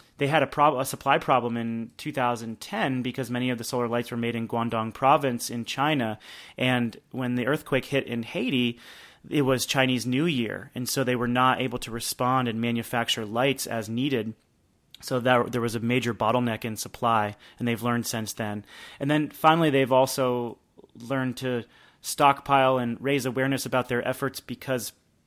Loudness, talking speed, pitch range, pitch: -26 LUFS, 180 wpm, 115-135 Hz, 125 Hz